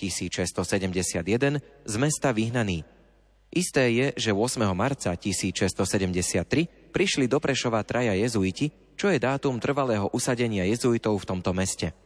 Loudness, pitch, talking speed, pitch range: -26 LUFS, 110 Hz, 120 wpm, 95-135 Hz